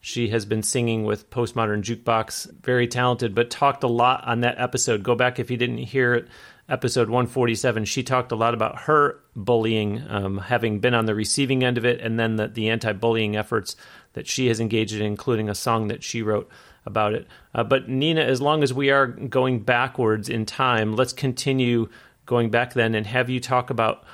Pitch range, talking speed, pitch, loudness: 110-125 Hz, 205 wpm, 120 Hz, -23 LUFS